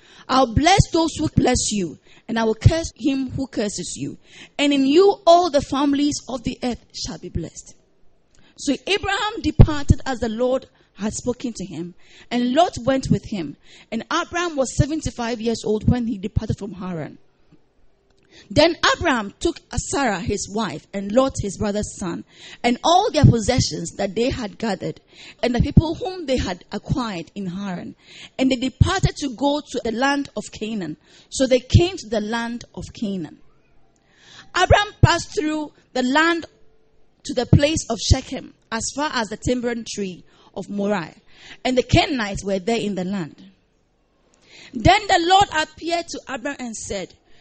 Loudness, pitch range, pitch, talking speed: -21 LUFS, 210-290 Hz, 250 Hz, 165 wpm